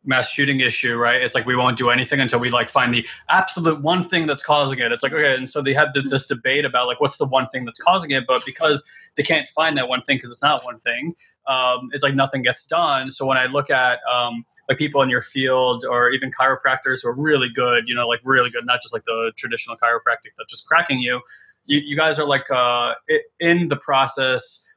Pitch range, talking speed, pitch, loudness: 125-145 Hz, 245 wpm, 130 Hz, -19 LUFS